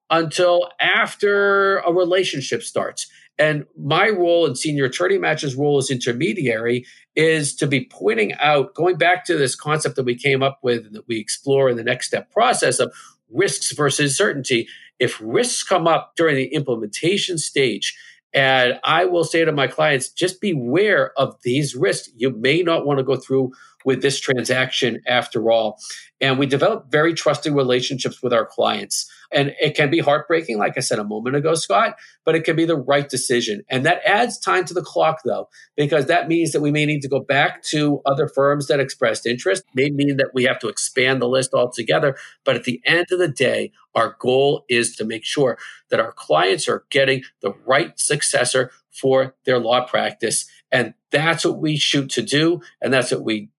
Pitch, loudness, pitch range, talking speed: 145 Hz, -19 LUFS, 130-165 Hz, 195 wpm